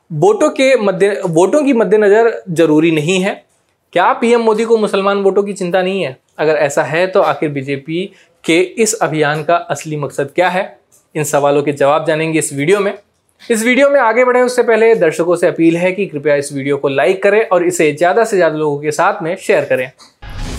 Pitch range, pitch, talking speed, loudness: 150-205 Hz, 175 Hz, 205 wpm, -13 LUFS